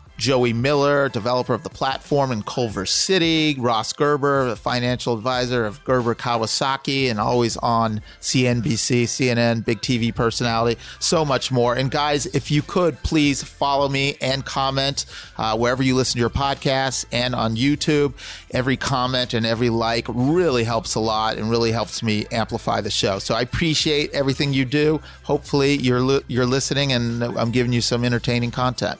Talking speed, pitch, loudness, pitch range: 165 wpm, 125 Hz, -20 LUFS, 115-140 Hz